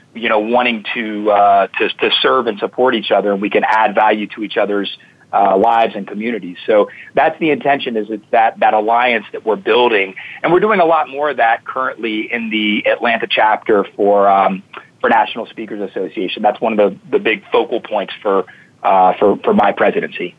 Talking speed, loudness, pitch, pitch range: 205 wpm, -15 LUFS, 115 Hz, 105-140 Hz